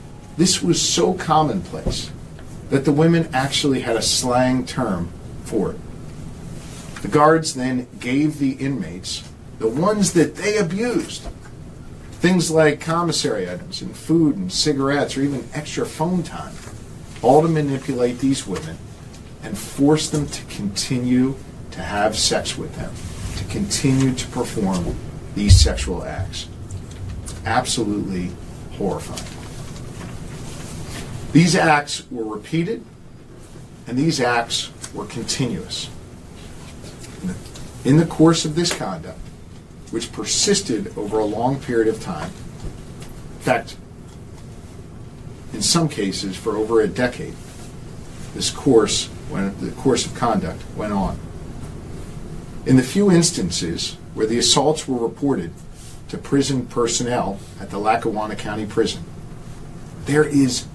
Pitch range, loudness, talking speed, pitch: 110-150 Hz, -20 LUFS, 120 wpm, 130 Hz